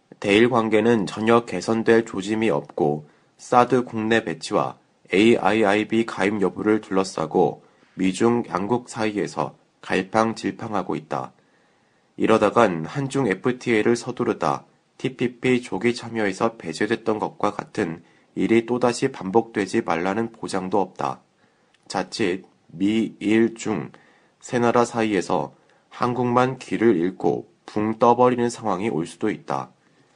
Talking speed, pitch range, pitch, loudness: 260 characters per minute, 100-120 Hz, 115 Hz, -22 LUFS